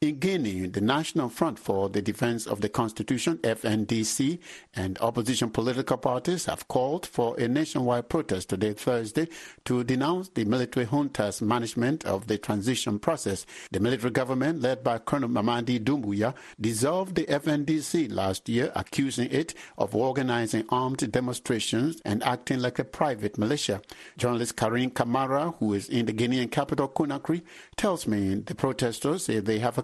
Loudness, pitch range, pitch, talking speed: -28 LUFS, 110-140 Hz, 125 Hz, 155 wpm